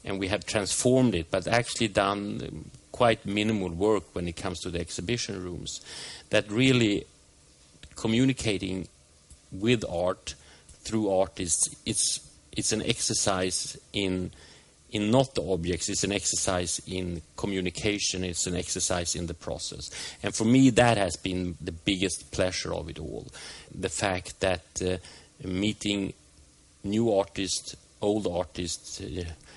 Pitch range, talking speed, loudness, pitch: 85-105 Hz, 135 wpm, -28 LUFS, 95 Hz